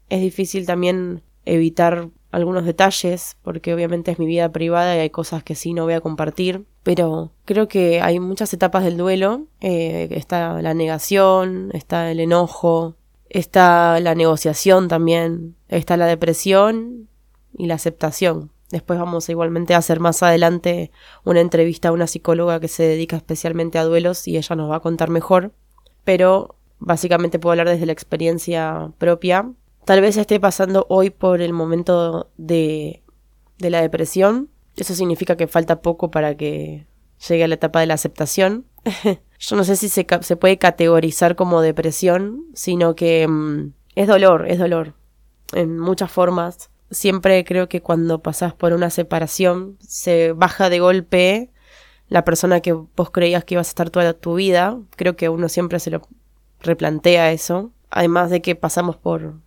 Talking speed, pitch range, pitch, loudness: 165 wpm, 165-185 Hz, 170 Hz, -18 LUFS